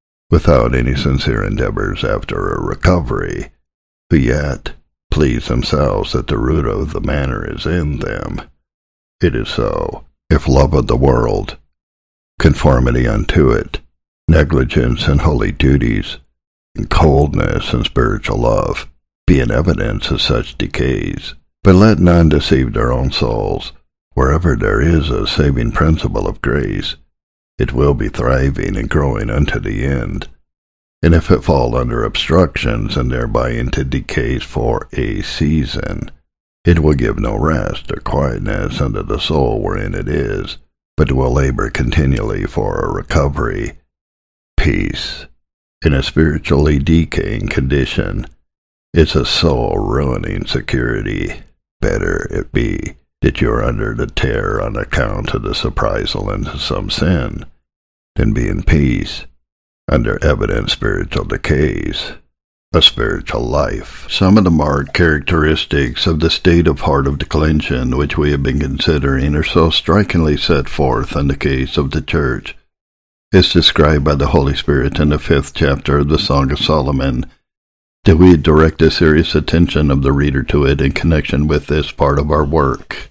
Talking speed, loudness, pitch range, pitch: 145 wpm, -15 LUFS, 70-80 Hz, 75 Hz